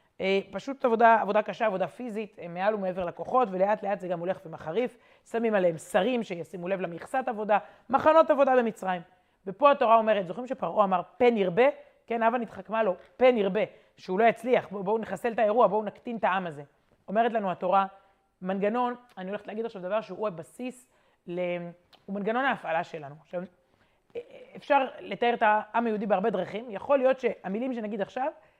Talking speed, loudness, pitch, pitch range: 165 wpm, -27 LUFS, 210 Hz, 185-240 Hz